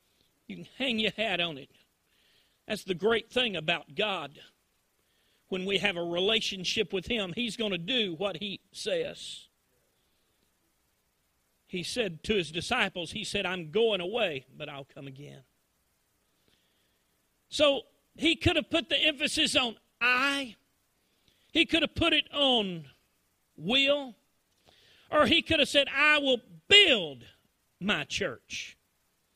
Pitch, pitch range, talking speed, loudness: 215 Hz, 170-275 Hz, 135 wpm, -27 LUFS